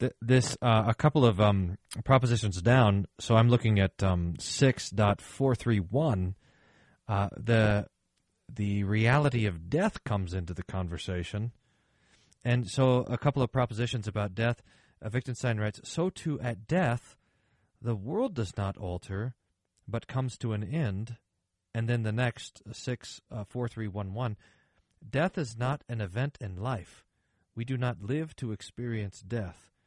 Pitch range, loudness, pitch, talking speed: 100-125 Hz, -30 LUFS, 115 Hz, 155 wpm